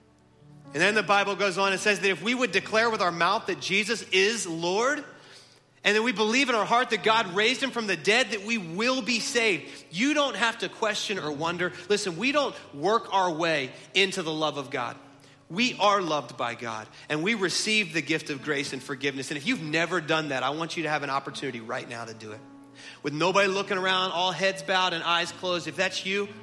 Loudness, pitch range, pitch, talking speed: -26 LUFS, 150-215 Hz, 185 Hz, 230 wpm